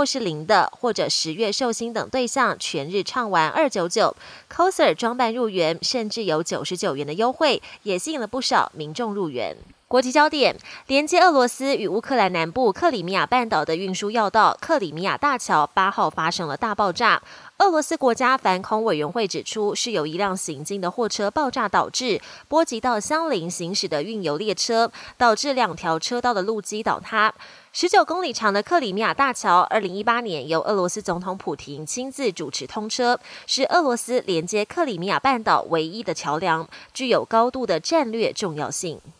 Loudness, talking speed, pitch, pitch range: -22 LUFS, 300 characters per minute, 220 Hz, 180-255 Hz